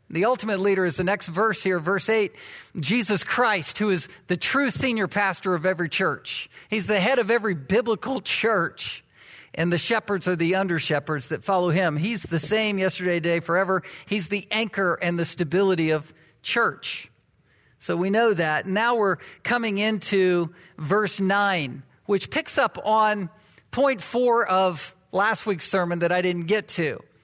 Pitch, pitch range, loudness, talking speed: 190 Hz, 175-215 Hz, -23 LUFS, 170 wpm